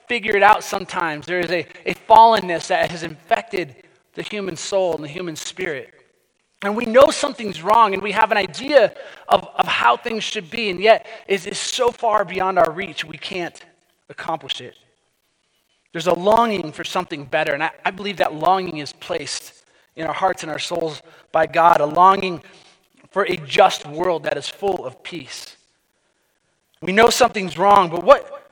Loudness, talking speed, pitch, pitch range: -19 LUFS, 185 wpm, 190 Hz, 170-220 Hz